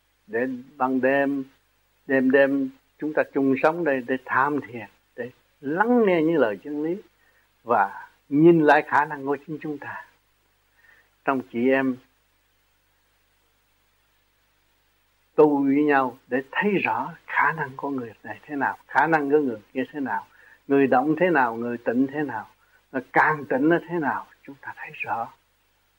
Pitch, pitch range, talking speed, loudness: 135 Hz, 110-150 Hz, 165 wpm, -23 LUFS